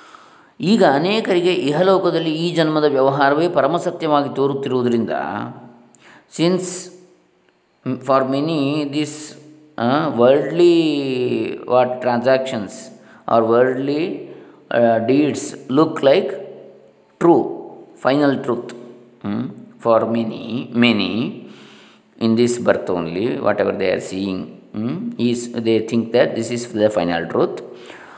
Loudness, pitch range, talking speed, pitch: -18 LUFS, 120-170 Hz, 95 wpm, 135 Hz